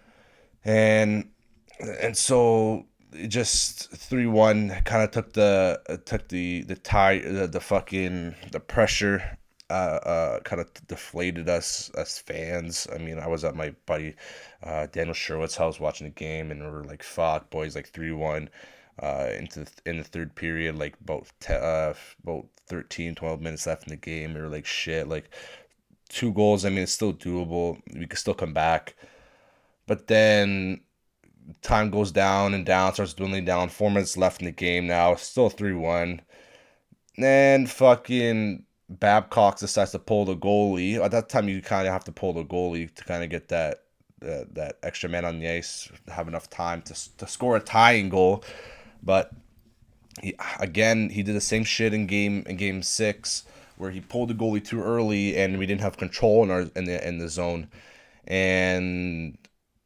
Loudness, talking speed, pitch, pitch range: -25 LUFS, 180 wpm, 95 Hz, 85-105 Hz